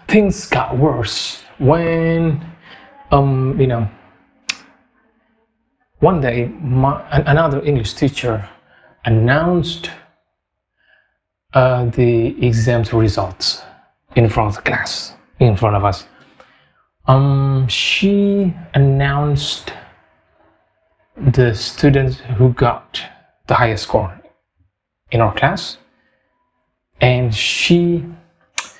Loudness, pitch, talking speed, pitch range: -16 LUFS, 135 Hz, 90 wpm, 120-170 Hz